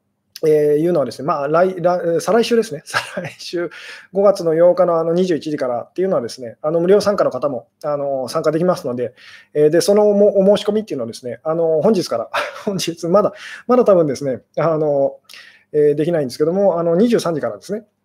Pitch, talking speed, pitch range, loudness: 170 Hz, 390 characters per minute, 150-200 Hz, -17 LUFS